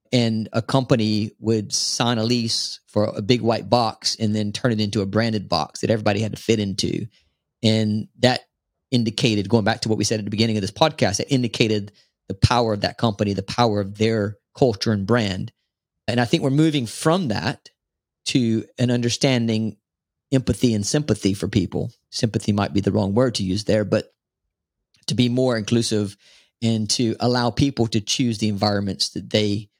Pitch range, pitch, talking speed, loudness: 105-120 Hz, 110 Hz, 190 wpm, -21 LUFS